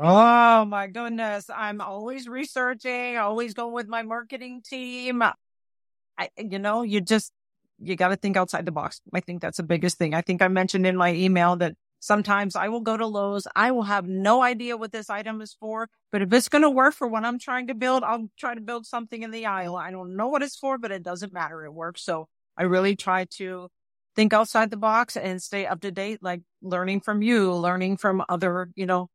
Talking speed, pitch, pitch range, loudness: 225 wpm, 205 Hz, 185-235 Hz, -24 LUFS